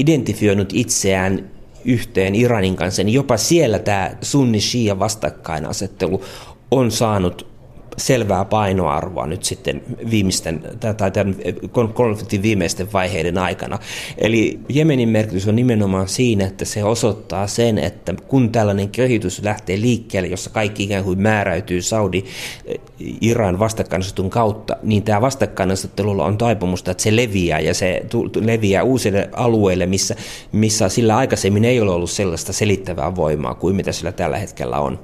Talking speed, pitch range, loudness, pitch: 135 wpm, 95-115 Hz, -18 LUFS, 105 Hz